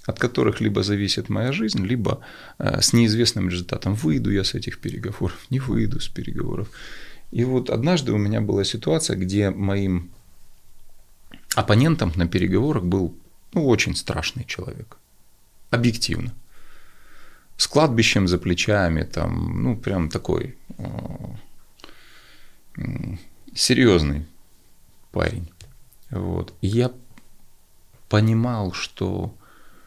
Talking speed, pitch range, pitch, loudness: 100 wpm, 95-120 Hz, 105 Hz, -22 LUFS